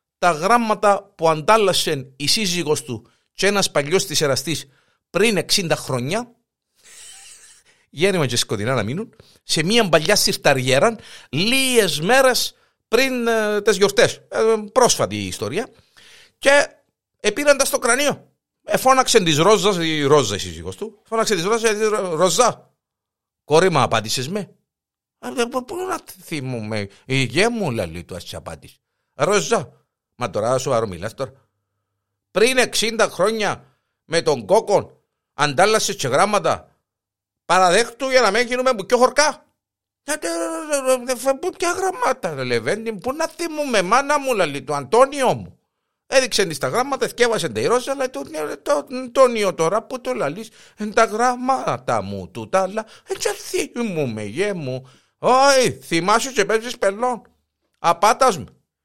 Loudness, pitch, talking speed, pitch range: -19 LUFS, 210 Hz, 135 wpm, 150-255 Hz